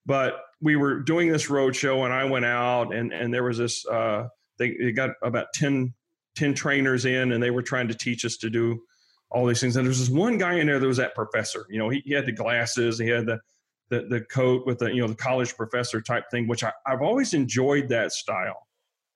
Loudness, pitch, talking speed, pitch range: -25 LUFS, 125 Hz, 245 wpm, 120-135 Hz